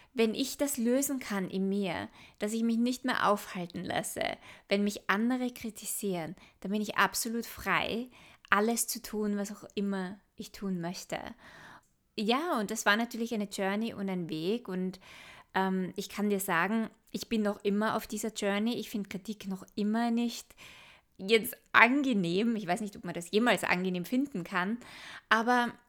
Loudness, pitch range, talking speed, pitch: -31 LUFS, 195-230 Hz, 170 wpm, 210 Hz